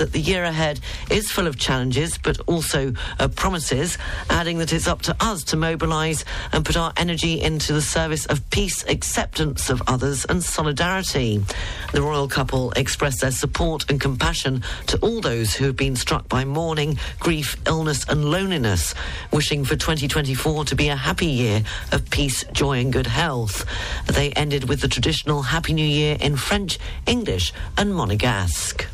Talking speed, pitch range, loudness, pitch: 170 wpm, 125-155 Hz, -22 LUFS, 140 Hz